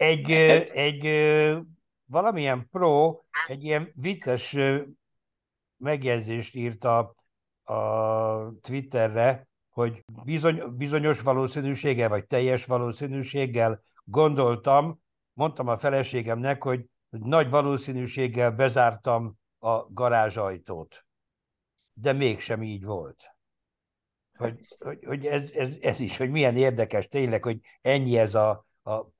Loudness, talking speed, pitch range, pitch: -26 LUFS, 95 wpm, 115-145 Hz, 130 Hz